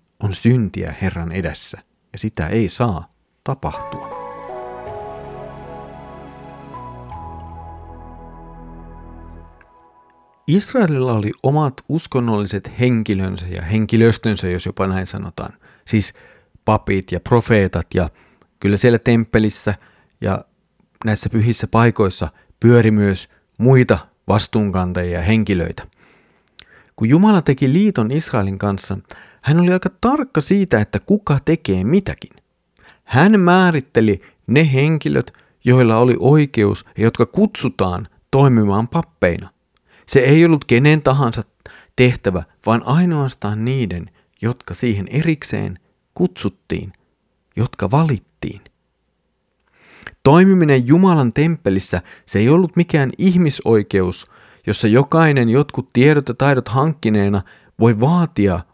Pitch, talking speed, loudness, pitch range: 110 Hz, 100 wpm, -16 LUFS, 95-140 Hz